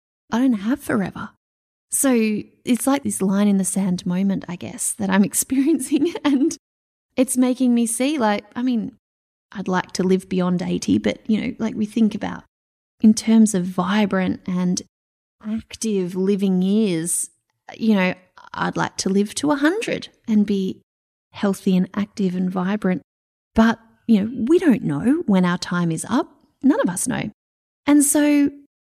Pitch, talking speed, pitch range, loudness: 215 Hz, 165 wpm, 190-255 Hz, -20 LUFS